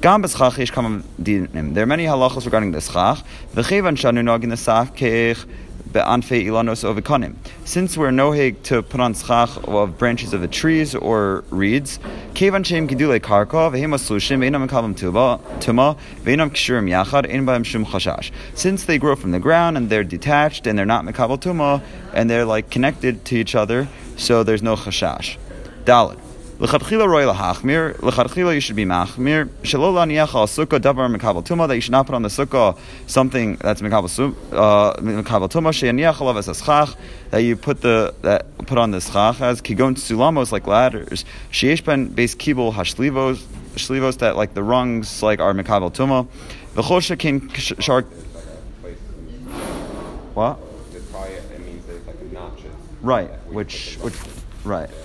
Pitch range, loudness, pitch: 105-140 Hz, -18 LUFS, 120 Hz